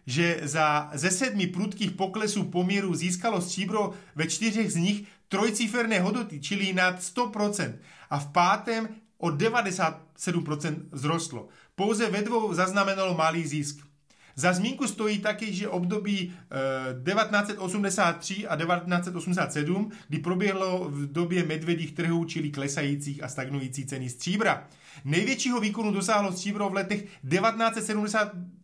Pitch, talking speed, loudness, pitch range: 185 Hz, 120 wpm, -28 LUFS, 160-205 Hz